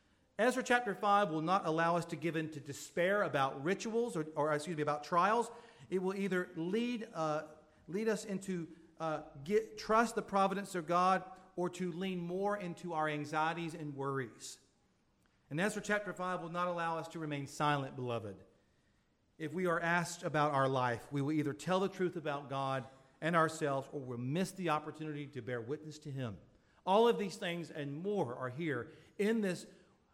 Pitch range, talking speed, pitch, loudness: 145-190 Hz, 185 wpm, 165 Hz, -36 LUFS